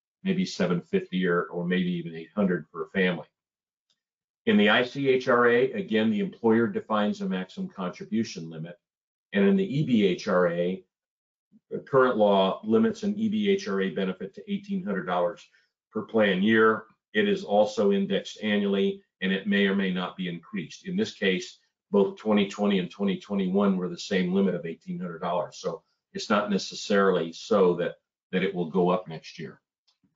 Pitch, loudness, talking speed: 105 Hz, -26 LUFS, 150 wpm